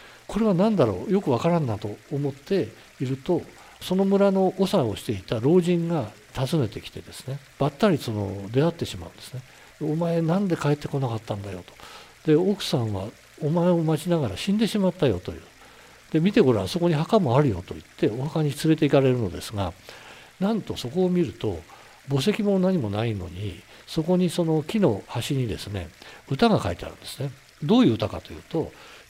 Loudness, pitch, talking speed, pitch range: -24 LUFS, 145 Hz, 380 characters per minute, 115-180 Hz